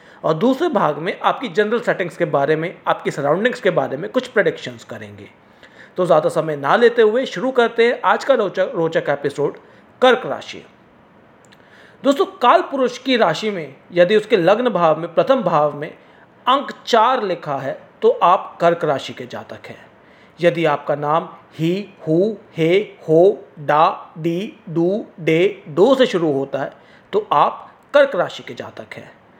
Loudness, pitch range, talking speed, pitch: -18 LUFS, 160-245 Hz, 155 wpm, 185 Hz